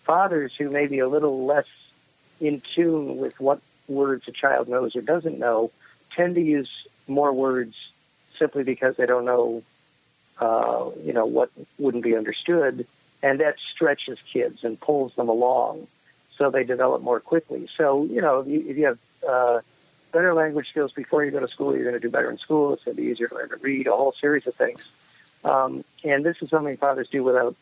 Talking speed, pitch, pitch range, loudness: 200 wpm, 135 Hz, 125-145 Hz, -24 LUFS